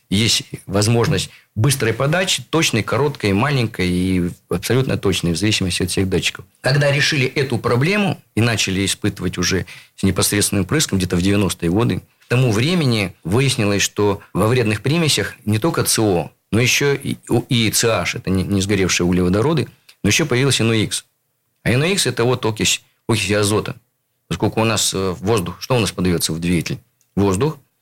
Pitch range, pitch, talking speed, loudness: 95-130 Hz, 110 Hz, 155 wpm, -18 LUFS